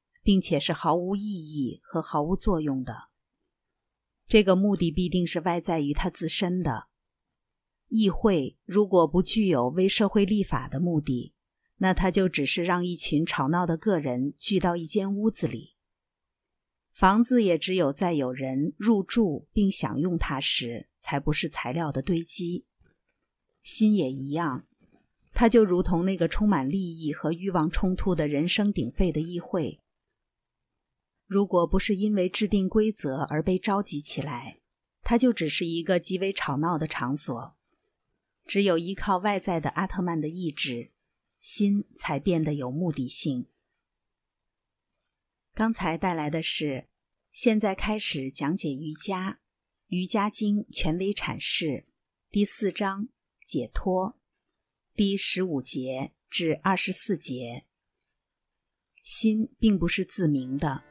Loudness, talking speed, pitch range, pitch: -25 LUFS, 200 characters per minute, 150-200 Hz, 180 Hz